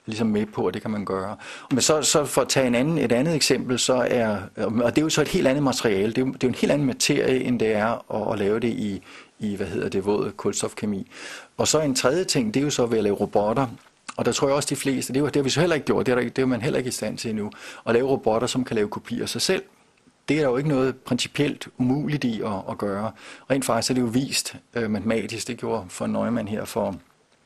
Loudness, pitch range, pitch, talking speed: -23 LUFS, 110-135 Hz, 125 Hz, 290 wpm